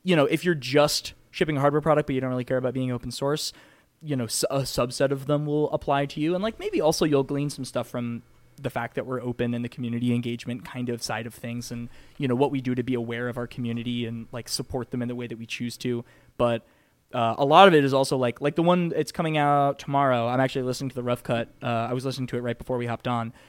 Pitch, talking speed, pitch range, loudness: 130 Hz, 275 wpm, 120-145 Hz, -25 LUFS